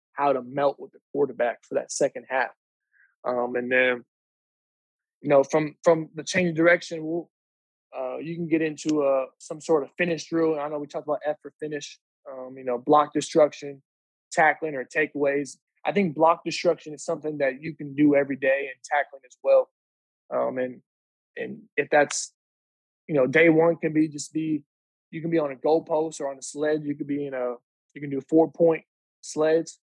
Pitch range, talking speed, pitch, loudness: 135-160 Hz, 200 wpm, 150 Hz, -25 LUFS